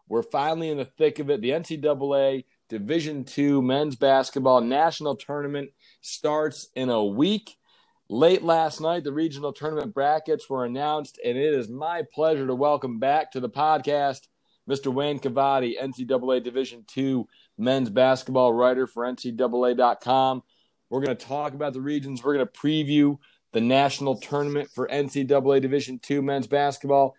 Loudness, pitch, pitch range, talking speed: -24 LUFS, 140 Hz, 130-150 Hz, 155 wpm